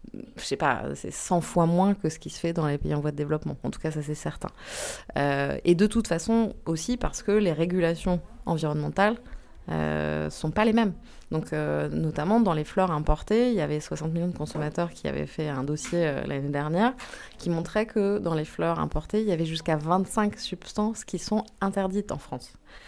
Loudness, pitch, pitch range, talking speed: -27 LUFS, 165 Hz, 150-200 Hz, 215 wpm